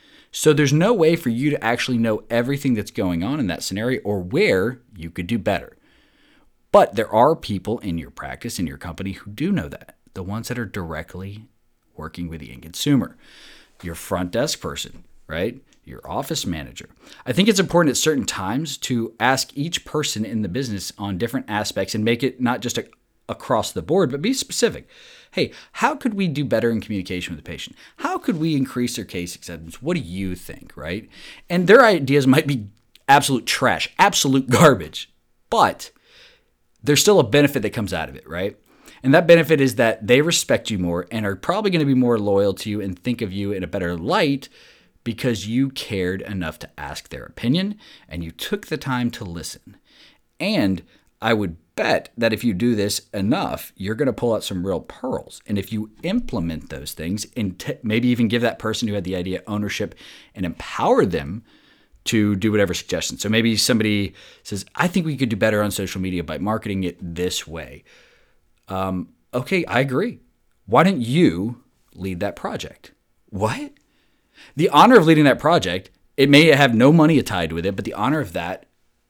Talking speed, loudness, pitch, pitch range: 195 wpm, -20 LUFS, 110 Hz, 95-140 Hz